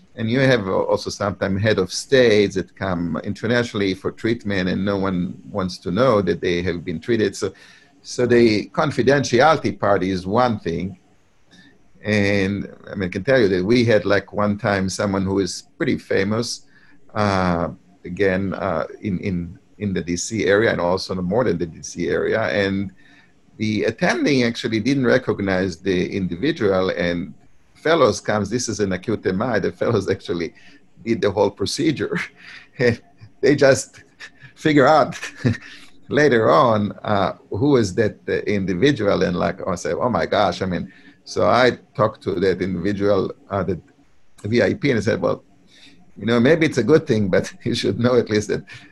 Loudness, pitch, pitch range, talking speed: -20 LUFS, 100 Hz, 95-115 Hz, 170 wpm